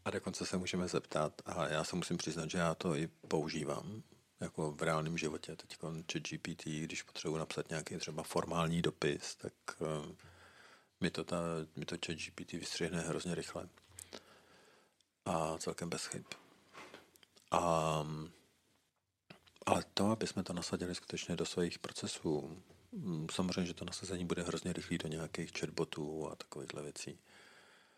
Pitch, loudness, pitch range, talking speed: 85 Hz, -40 LUFS, 80-90 Hz, 145 wpm